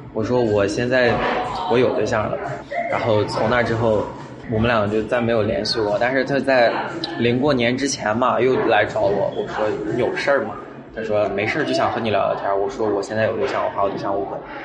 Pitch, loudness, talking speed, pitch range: 115 Hz, -20 LUFS, 305 characters per minute, 105-125 Hz